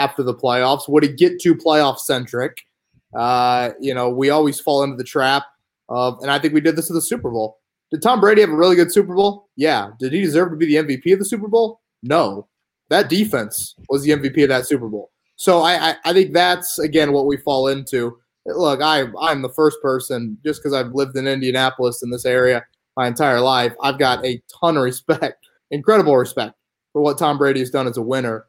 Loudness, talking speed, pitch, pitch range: -18 LUFS, 225 wpm, 140 Hz, 125-160 Hz